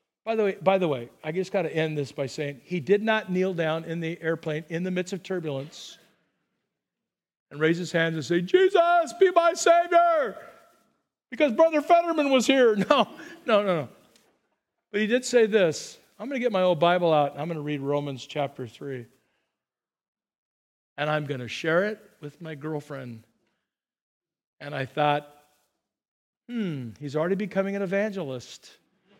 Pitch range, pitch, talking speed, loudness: 145-225 Hz, 175 Hz, 175 wpm, -25 LUFS